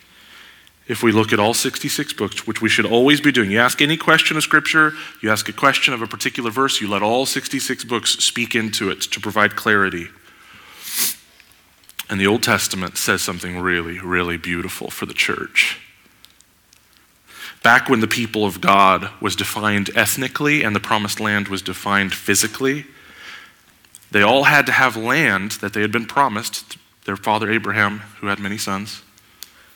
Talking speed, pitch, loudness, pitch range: 170 wpm, 110 Hz, -18 LUFS, 100-130 Hz